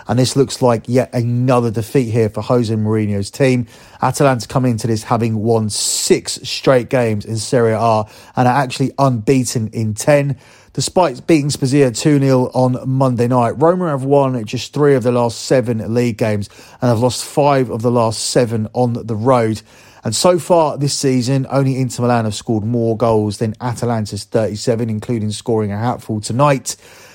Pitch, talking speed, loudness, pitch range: 120 Hz, 175 wpm, -16 LUFS, 115-135 Hz